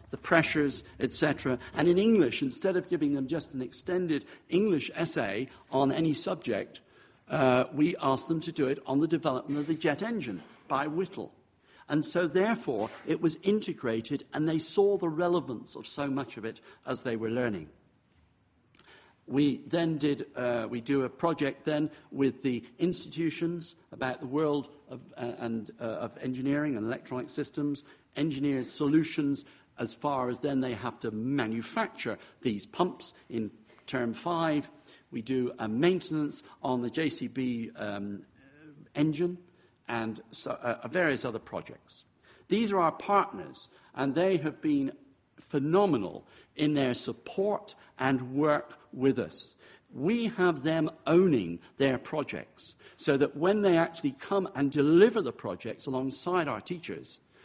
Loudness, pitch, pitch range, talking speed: -30 LUFS, 145 Hz, 130-170 Hz, 150 wpm